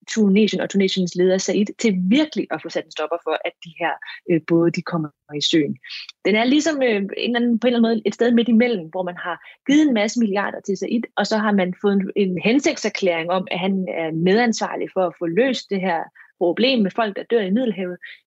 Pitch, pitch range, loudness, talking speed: 200 Hz, 180-230 Hz, -20 LUFS, 240 wpm